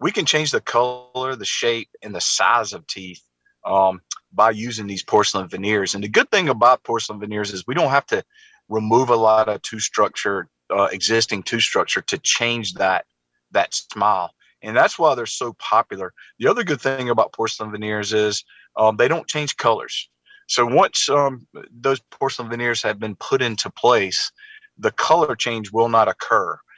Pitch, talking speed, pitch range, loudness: 115 Hz, 180 wpm, 105-135 Hz, -20 LUFS